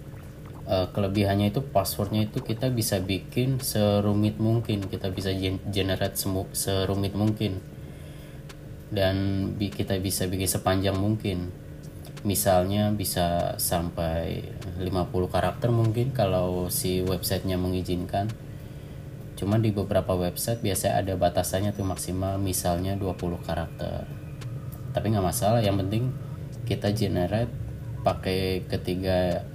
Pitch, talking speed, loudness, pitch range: 100 Hz, 105 wpm, -27 LUFS, 95-110 Hz